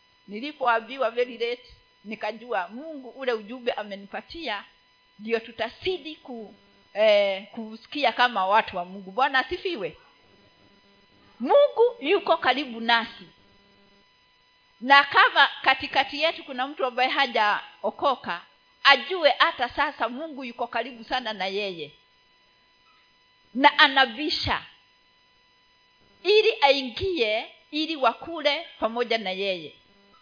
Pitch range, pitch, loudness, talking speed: 215-290 Hz, 250 Hz, -24 LUFS, 95 wpm